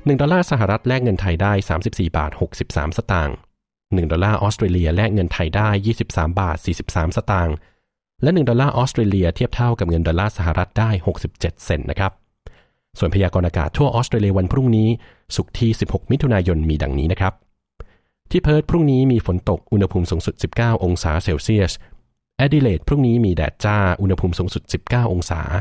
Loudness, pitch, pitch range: -19 LUFS, 95 Hz, 90-115 Hz